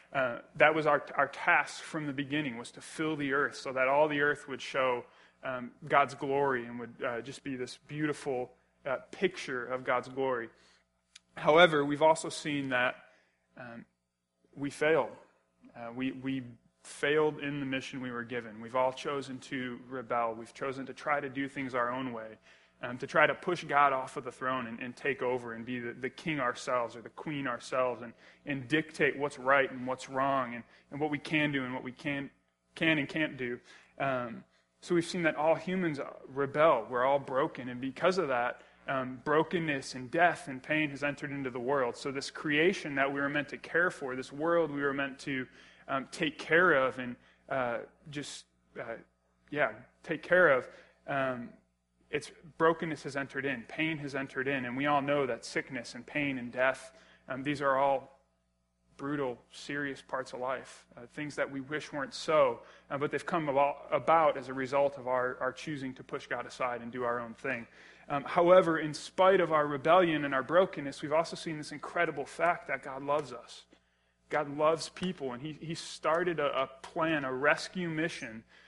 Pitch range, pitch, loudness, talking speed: 125-150 Hz, 140 Hz, -32 LUFS, 200 wpm